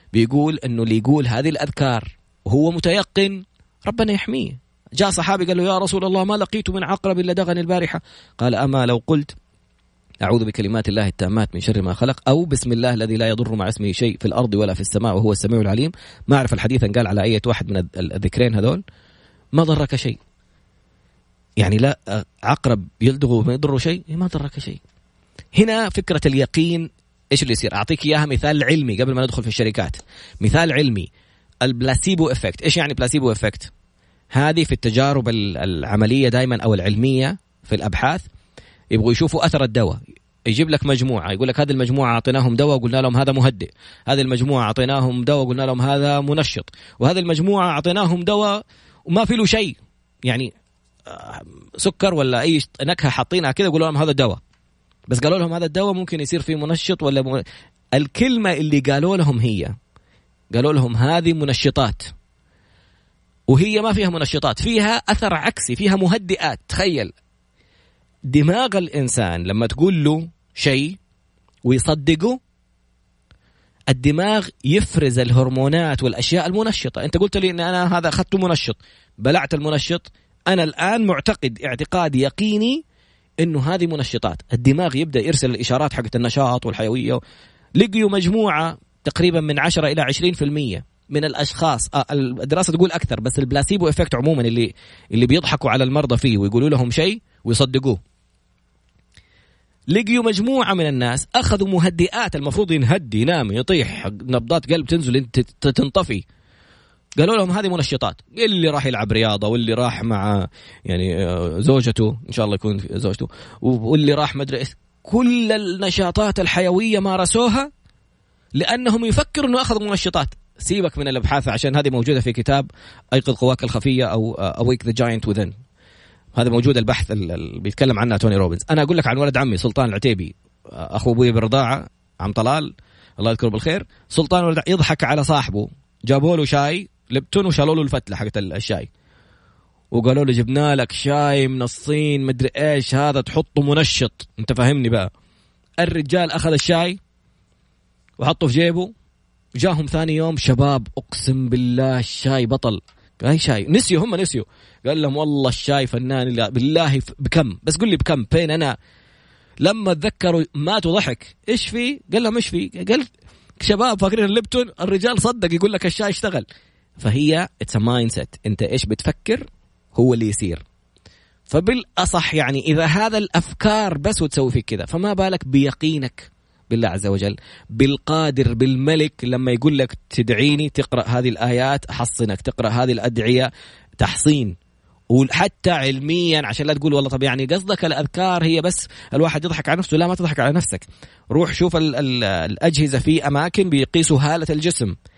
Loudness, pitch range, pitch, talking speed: -19 LUFS, 120-170 Hz, 140 Hz, 145 wpm